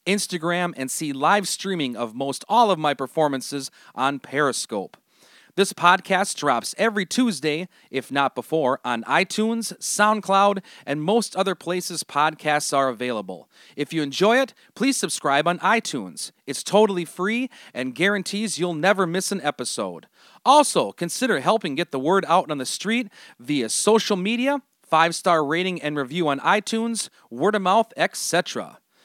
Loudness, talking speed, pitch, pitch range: -22 LUFS, 150 wpm, 180 Hz, 145-205 Hz